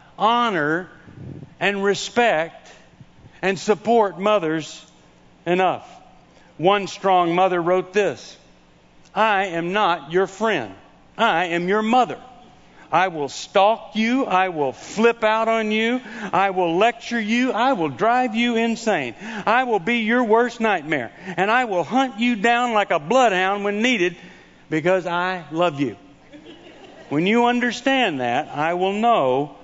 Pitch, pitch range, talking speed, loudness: 205 Hz, 175-235 Hz, 140 wpm, -20 LUFS